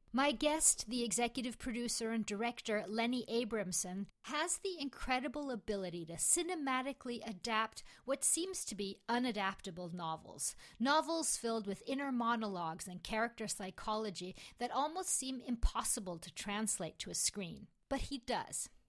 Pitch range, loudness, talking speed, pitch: 200-265 Hz, -38 LUFS, 135 wpm, 230 Hz